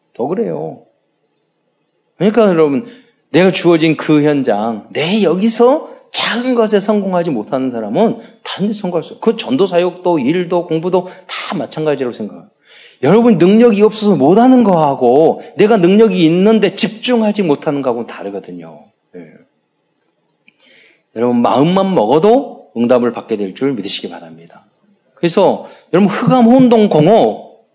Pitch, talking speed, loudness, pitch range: 180 Hz, 310 characters per minute, -12 LUFS, 140-225 Hz